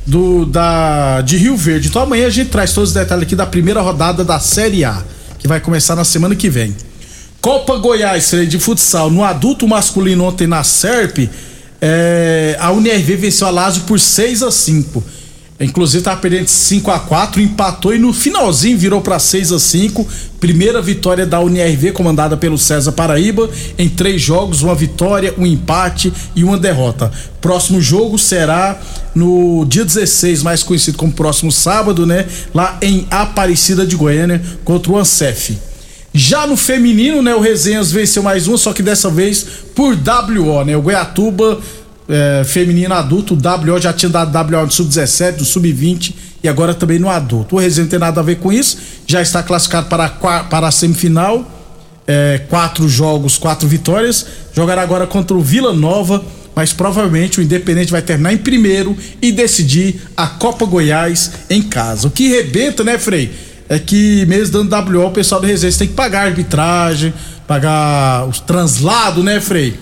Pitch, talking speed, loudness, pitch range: 175 Hz, 175 wpm, -11 LUFS, 160-200 Hz